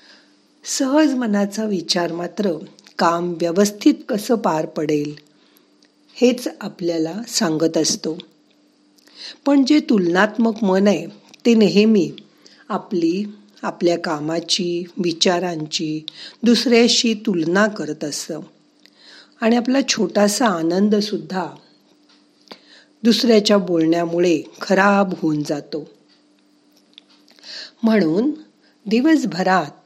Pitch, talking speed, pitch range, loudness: 200 Hz, 80 wpm, 170-230 Hz, -18 LUFS